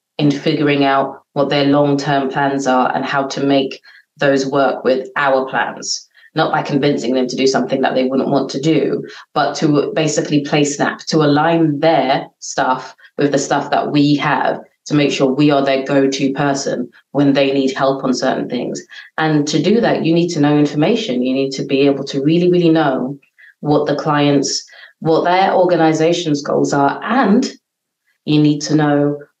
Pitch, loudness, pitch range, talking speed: 145 Hz, -15 LUFS, 135-150 Hz, 190 wpm